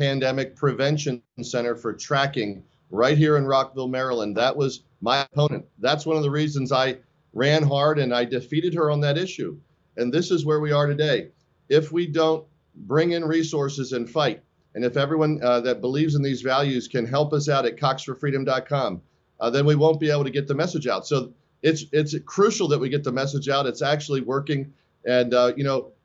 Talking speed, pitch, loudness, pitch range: 200 wpm, 140 Hz, -23 LUFS, 130-155 Hz